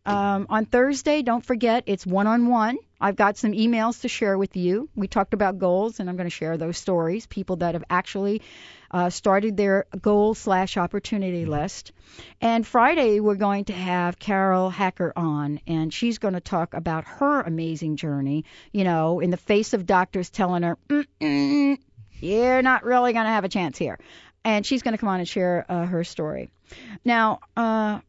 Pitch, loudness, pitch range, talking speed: 200 Hz, -23 LUFS, 180-230 Hz, 185 wpm